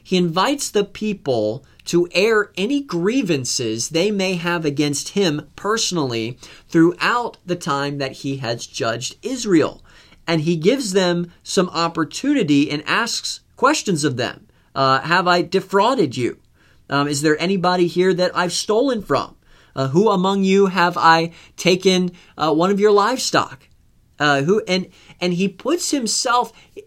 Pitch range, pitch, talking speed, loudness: 150-200 Hz, 175 Hz, 145 wpm, -19 LUFS